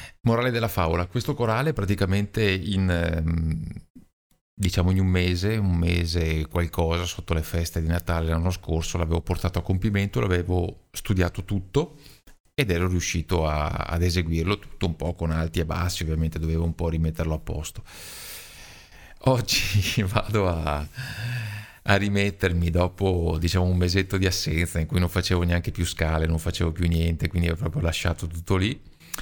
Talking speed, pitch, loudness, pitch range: 155 wpm, 90 Hz, -25 LUFS, 85-100 Hz